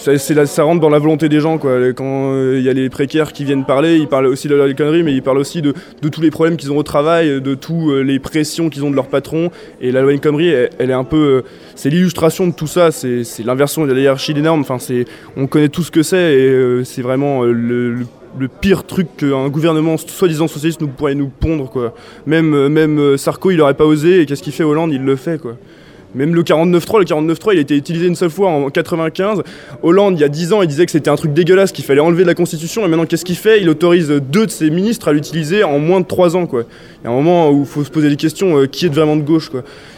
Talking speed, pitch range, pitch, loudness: 280 wpm, 135-165 Hz, 155 Hz, -14 LUFS